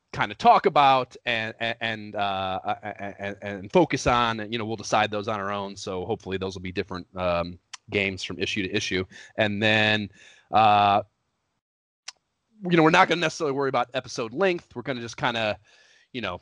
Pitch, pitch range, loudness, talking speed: 105 Hz, 100-120 Hz, -24 LUFS, 195 wpm